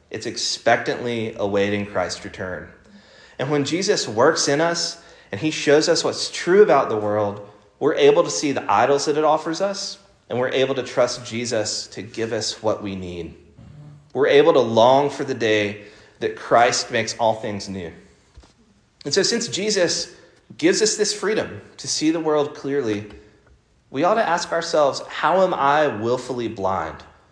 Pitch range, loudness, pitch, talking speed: 105-170 Hz, -20 LUFS, 130 Hz, 170 wpm